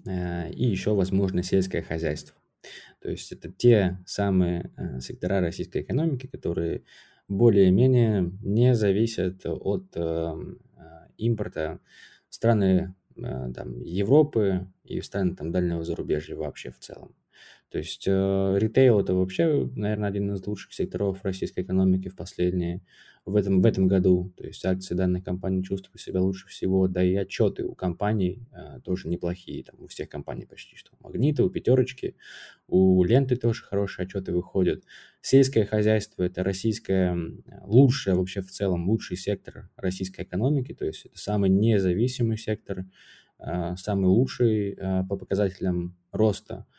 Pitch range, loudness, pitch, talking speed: 90-105 Hz, -26 LUFS, 95 Hz, 140 wpm